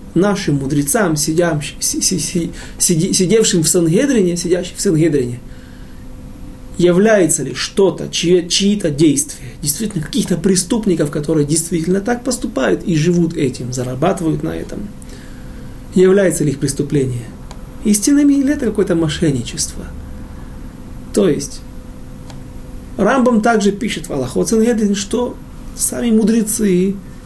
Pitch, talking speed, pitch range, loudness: 175 Hz, 100 wpm, 155-210 Hz, -15 LUFS